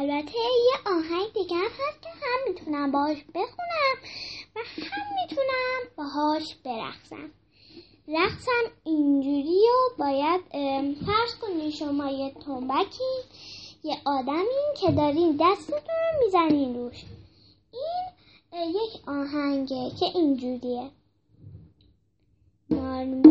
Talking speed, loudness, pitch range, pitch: 95 wpm, -27 LUFS, 275-375 Hz, 310 Hz